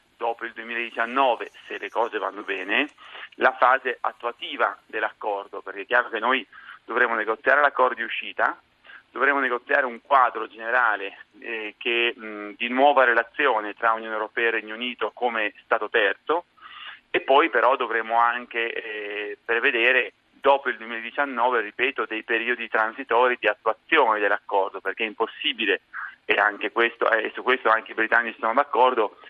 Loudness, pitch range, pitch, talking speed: -23 LUFS, 110-120 Hz, 115 Hz, 150 wpm